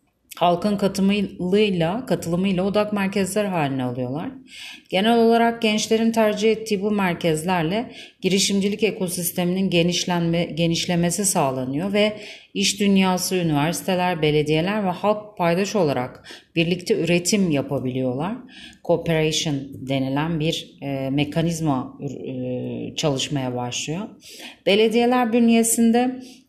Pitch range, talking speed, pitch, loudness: 155-210 Hz, 90 wpm, 180 Hz, -21 LUFS